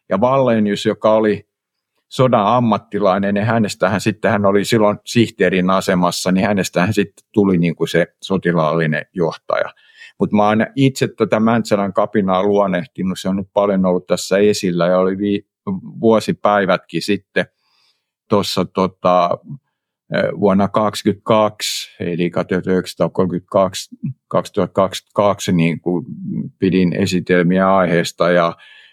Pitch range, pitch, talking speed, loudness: 90-105 Hz, 100 Hz, 120 wpm, -17 LUFS